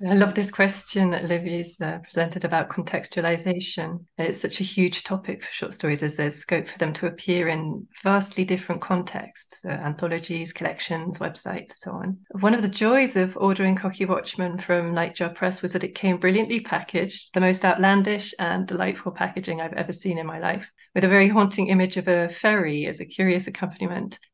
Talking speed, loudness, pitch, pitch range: 185 wpm, -24 LUFS, 185 Hz, 170-195 Hz